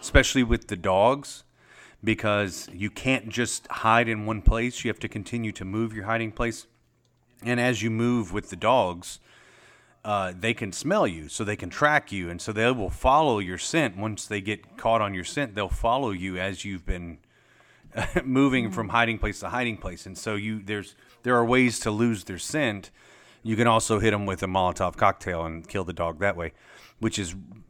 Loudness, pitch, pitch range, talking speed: -26 LUFS, 105 Hz, 95-115 Hz, 200 wpm